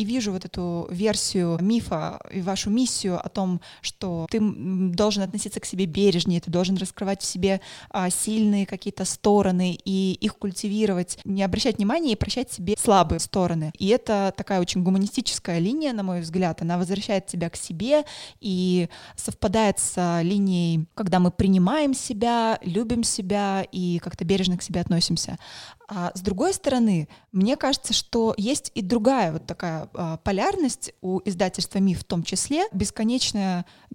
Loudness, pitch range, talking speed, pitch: -24 LUFS, 180-220 Hz, 155 wpm, 195 Hz